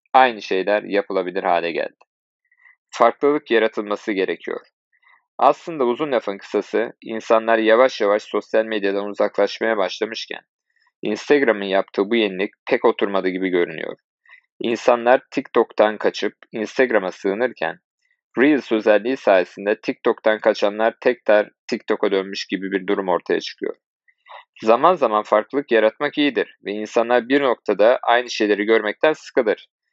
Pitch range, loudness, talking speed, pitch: 100-125 Hz, -20 LUFS, 115 wpm, 110 Hz